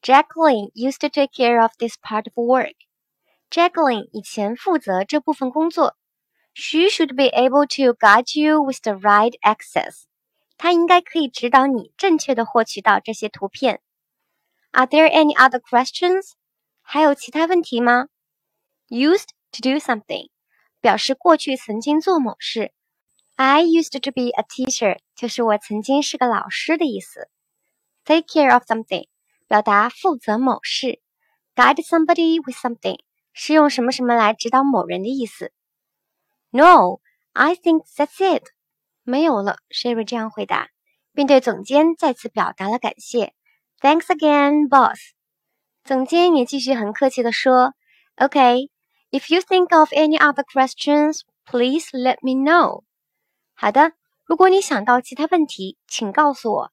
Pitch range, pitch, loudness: 240-310 Hz, 270 Hz, -18 LUFS